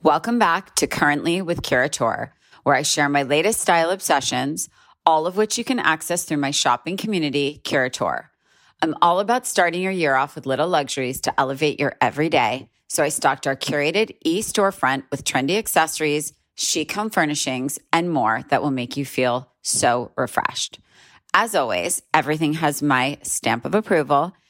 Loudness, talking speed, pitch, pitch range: -21 LUFS, 165 wpm, 150 Hz, 140-180 Hz